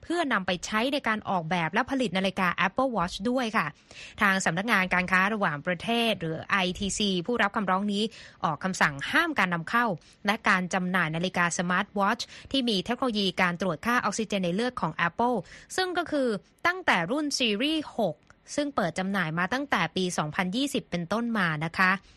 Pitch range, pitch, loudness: 180-240 Hz, 200 Hz, -27 LUFS